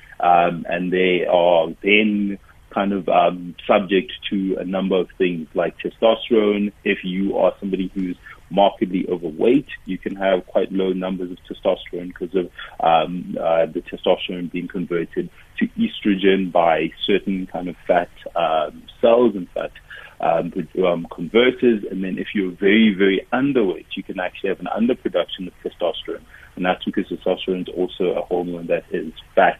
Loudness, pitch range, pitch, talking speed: -20 LUFS, 90-100 Hz, 95 Hz, 160 wpm